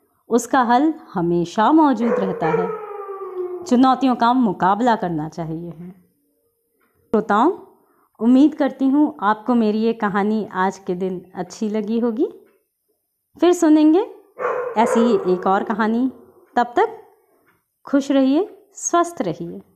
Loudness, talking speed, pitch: -19 LUFS, 115 wpm, 255 Hz